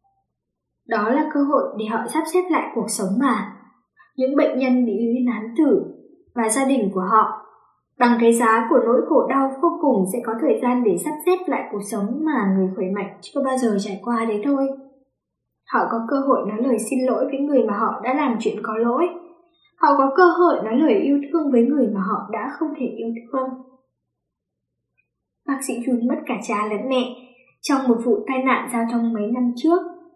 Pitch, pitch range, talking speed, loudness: 250 Hz, 225-285 Hz, 210 wpm, -20 LUFS